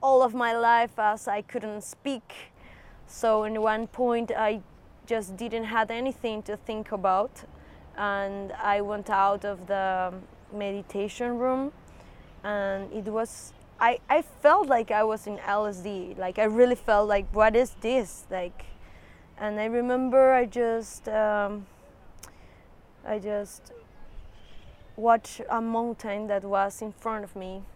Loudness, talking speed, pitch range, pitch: -27 LUFS, 140 wpm, 200-230 Hz, 215 Hz